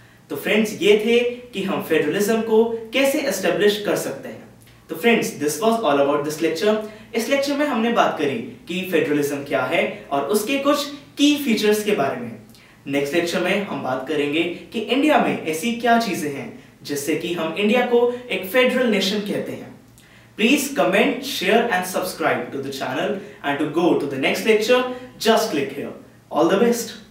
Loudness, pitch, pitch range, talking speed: -20 LUFS, 210 Hz, 160-235 Hz, 185 wpm